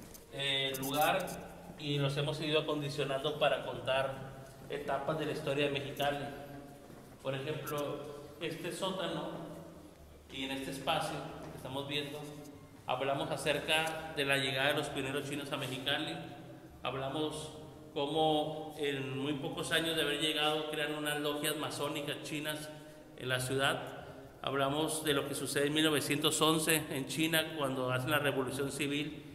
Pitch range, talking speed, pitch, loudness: 140-155 Hz, 140 wpm, 145 Hz, -34 LUFS